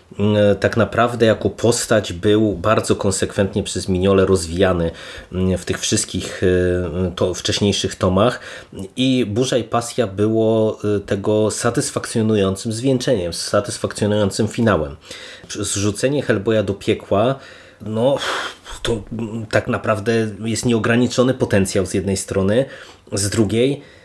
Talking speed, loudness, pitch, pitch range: 105 wpm, -19 LUFS, 105 Hz, 100-115 Hz